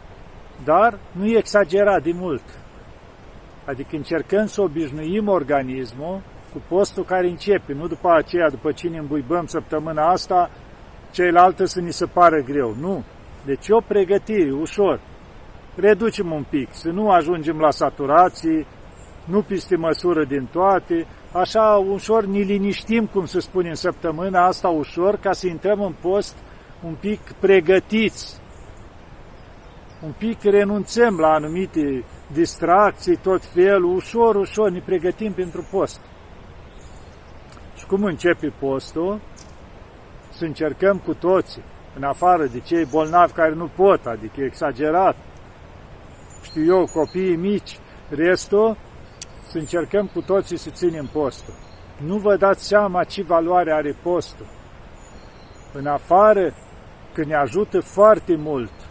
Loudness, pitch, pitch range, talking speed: -20 LUFS, 175 Hz, 150-195 Hz, 125 wpm